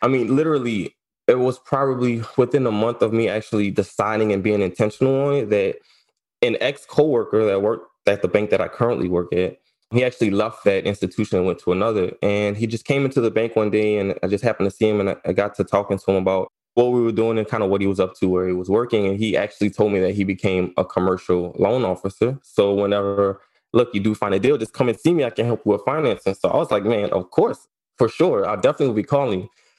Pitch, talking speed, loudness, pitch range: 110 Hz, 255 wpm, -20 LUFS, 100-125 Hz